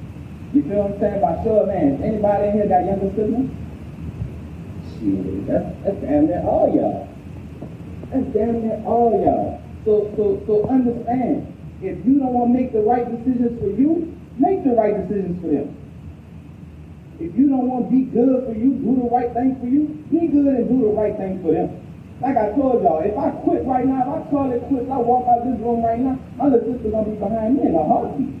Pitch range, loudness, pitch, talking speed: 215-260 Hz, -19 LUFS, 240 Hz, 210 wpm